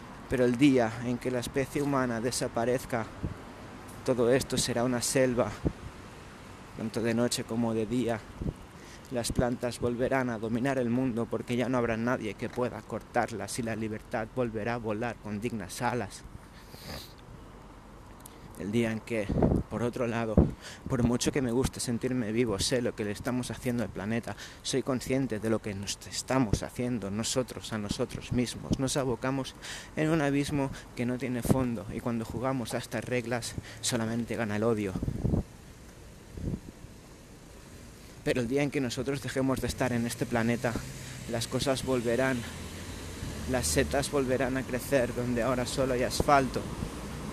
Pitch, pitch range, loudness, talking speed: 120 Hz, 110-130 Hz, -31 LUFS, 155 wpm